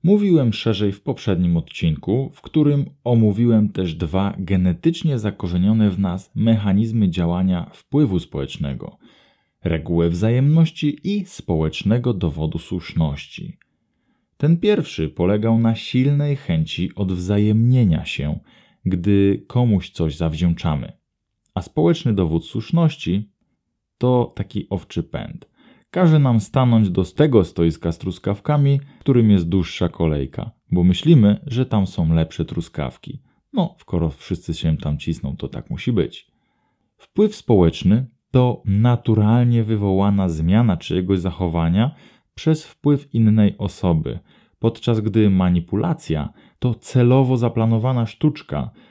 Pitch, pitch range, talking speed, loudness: 105 Hz, 90-125 Hz, 115 wpm, -19 LUFS